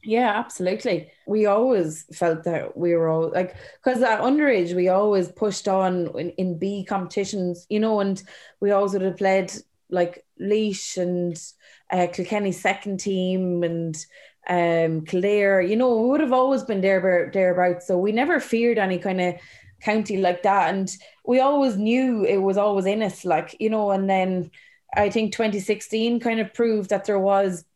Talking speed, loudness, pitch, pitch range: 175 wpm, -22 LUFS, 195 Hz, 180-215 Hz